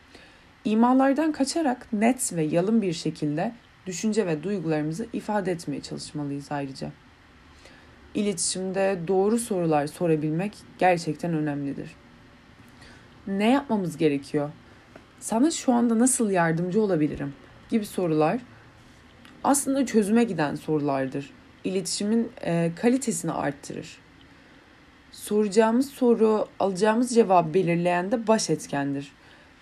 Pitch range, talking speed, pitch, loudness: 155-230 Hz, 95 wpm, 190 Hz, -25 LUFS